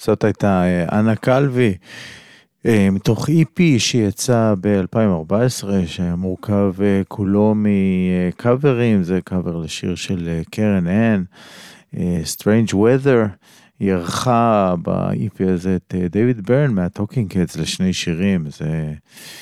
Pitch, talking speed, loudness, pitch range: 100 Hz, 100 wpm, -18 LUFS, 90-115 Hz